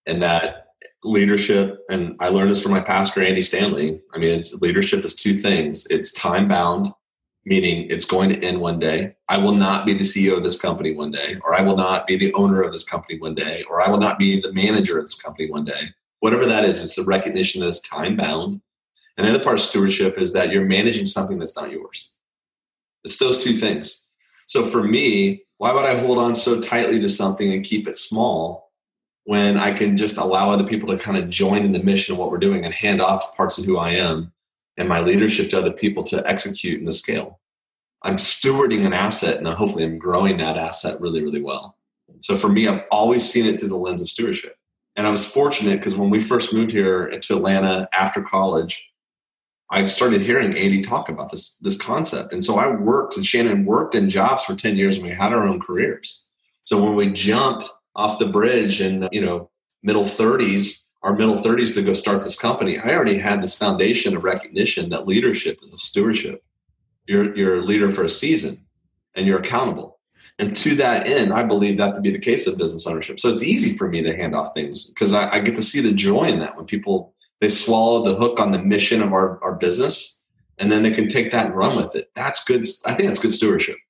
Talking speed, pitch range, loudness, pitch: 225 wpm, 95-120 Hz, -19 LUFS, 100 Hz